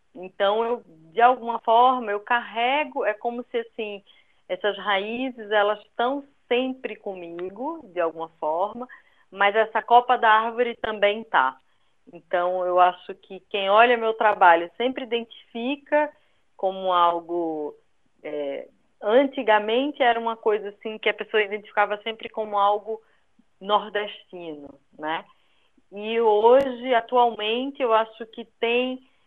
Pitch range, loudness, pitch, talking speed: 200-240 Hz, -23 LUFS, 220 Hz, 125 wpm